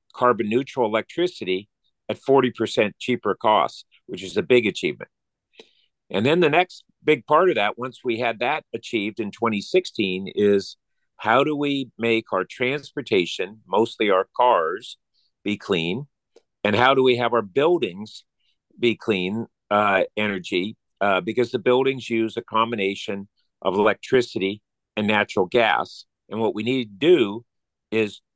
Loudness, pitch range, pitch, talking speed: -22 LUFS, 105-125 Hz, 115 Hz, 145 wpm